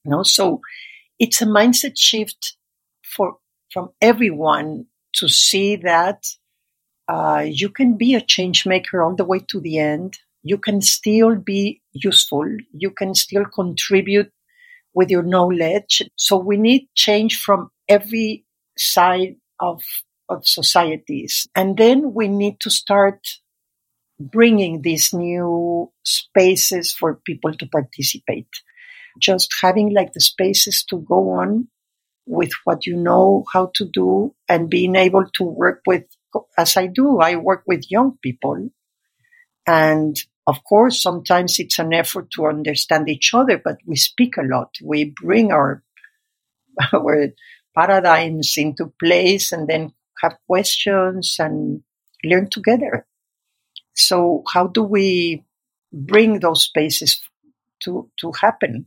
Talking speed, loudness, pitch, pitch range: 135 wpm, -17 LUFS, 190 Hz, 165-215 Hz